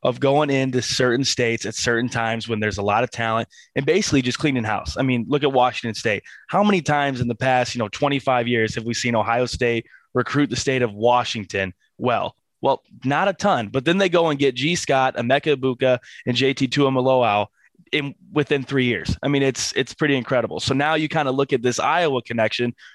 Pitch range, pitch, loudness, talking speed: 120-140 Hz, 125 Hz, -21 LUFS, 215 wpm